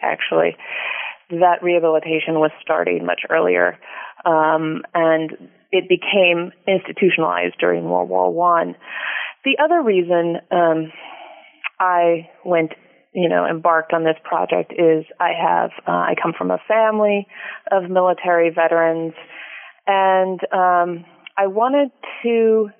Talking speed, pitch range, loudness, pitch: 120 wpm, 160-190 Hz, -18 LUFS, 170 Hz